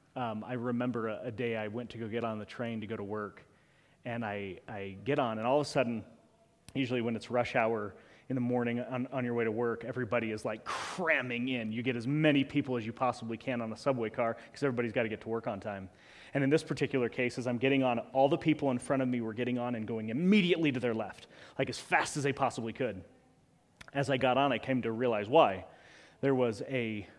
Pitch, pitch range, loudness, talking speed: 120 Hz, 115-135 Hz, -33 LUFS, 250 wpm